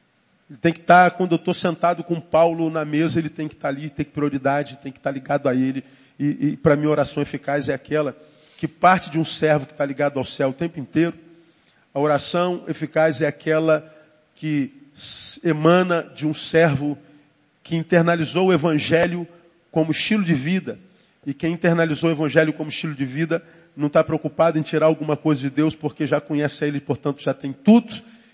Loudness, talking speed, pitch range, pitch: -21 LUFS, 200 wpm, 145-165 Hz, 155 Hz